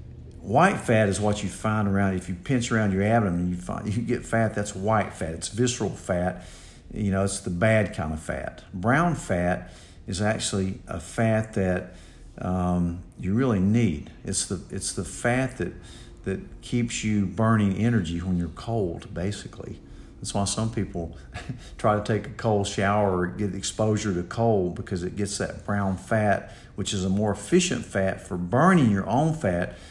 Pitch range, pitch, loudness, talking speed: 90-110 Hz, 100 Hz, -26 LUFS, 185 wpm